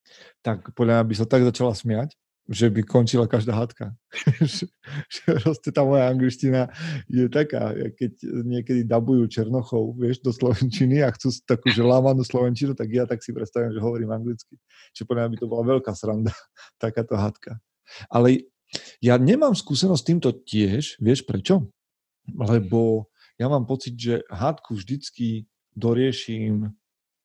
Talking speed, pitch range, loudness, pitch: 140 wpm, 115-130 Hz, -23 LUFS, 120 Hz